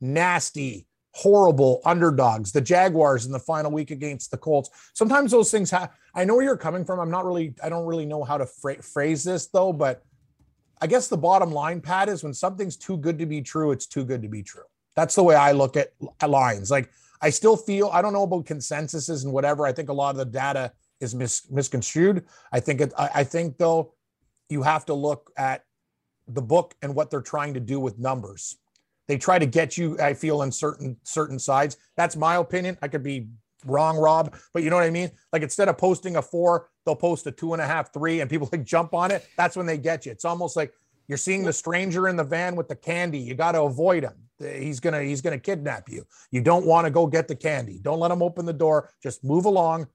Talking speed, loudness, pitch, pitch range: 235 wpm, -23 LUFS, 155 Hz, 140-175 Hz